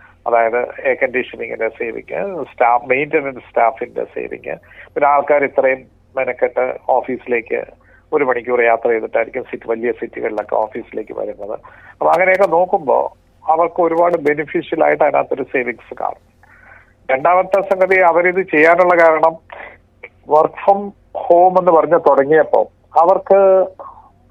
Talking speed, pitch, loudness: 105 wpm, 175 Hz, -15 LUFS